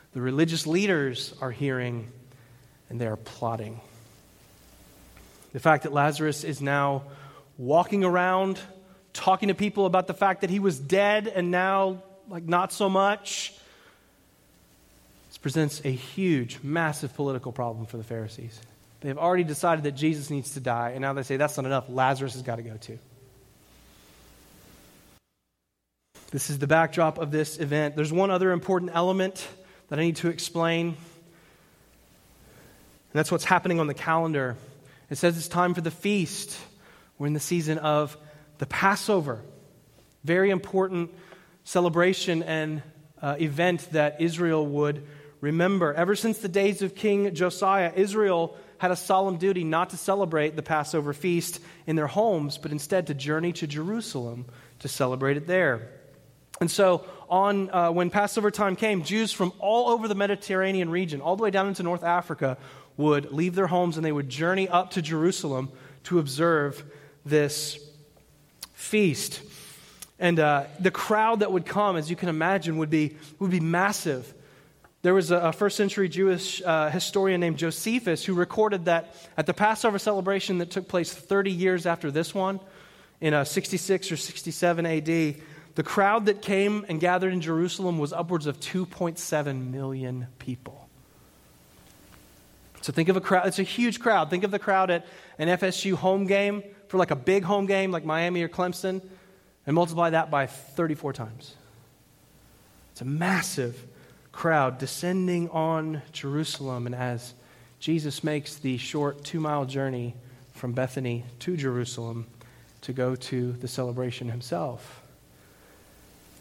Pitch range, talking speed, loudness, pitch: 140-185 Hz, 155 wpm, -26 LUFS, 165 Hz